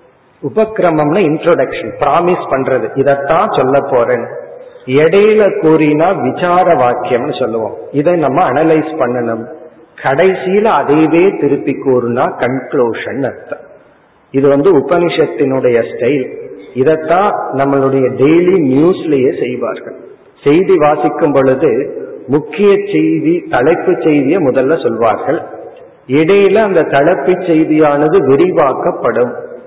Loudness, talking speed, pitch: -11 LUFS, 90 wpm, 175 Hz